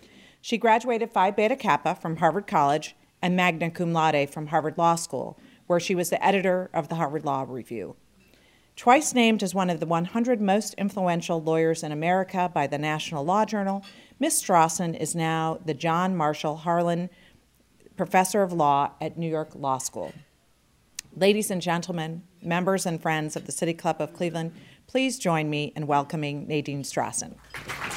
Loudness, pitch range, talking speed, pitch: -25 LUFS, 155-190 Hz, 165 wpm, 170 Hz